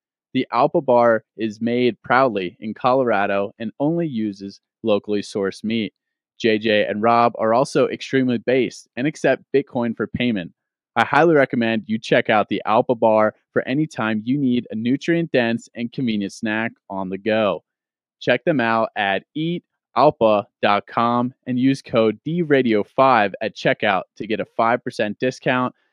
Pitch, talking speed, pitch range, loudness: 115 Hz, 150 wpm, 110-130 Hz, -20 LUFS